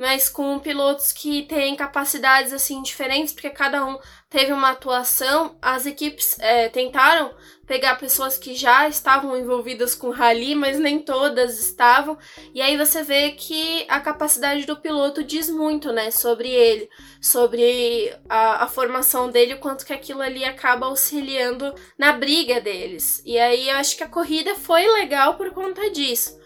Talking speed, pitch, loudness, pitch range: 165 wpm, 280 Hz, -19 LUFS, 260-305 Hz